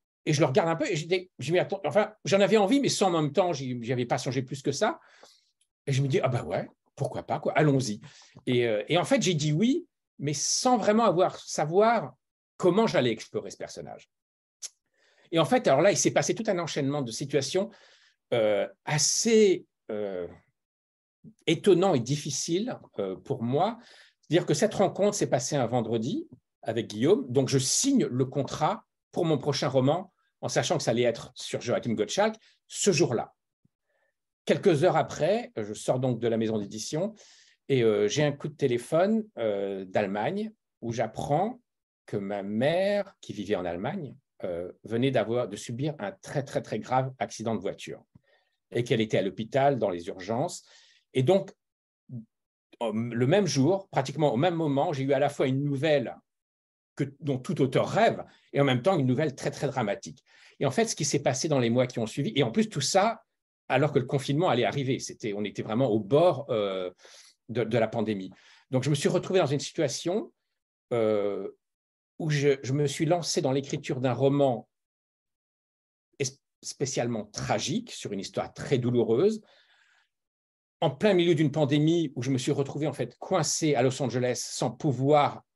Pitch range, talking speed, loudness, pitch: 120-175 Hz, 180 wpm, -27 LUFS, 140 Hz